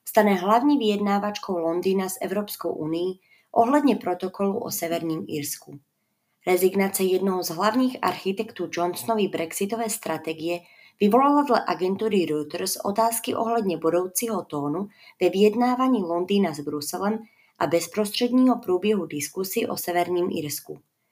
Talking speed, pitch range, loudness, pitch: 115 wpm, 175-220 Hz, -24 LUFS, 190 Hz